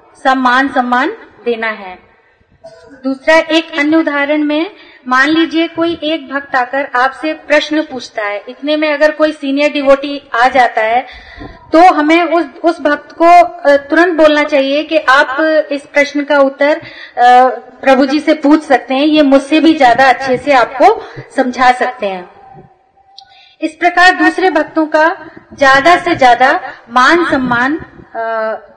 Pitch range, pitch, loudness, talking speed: 255-320 Hz, 295 Hz, -11 LUFS, 145 wpm